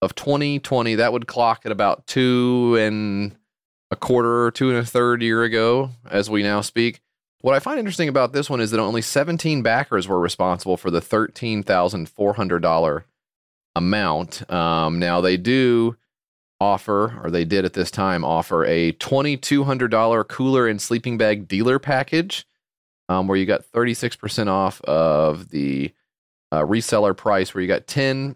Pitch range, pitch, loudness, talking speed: 95-130 Hz, 115 Hz, -20 LUFS, 180 wpm